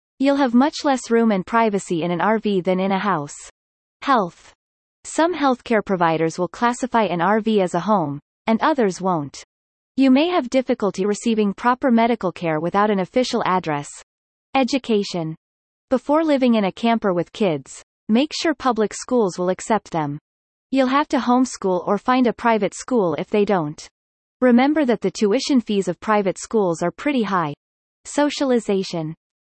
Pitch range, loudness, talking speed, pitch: 185-255 Hz, -20 LUFS, 160 wpm, 215 Hz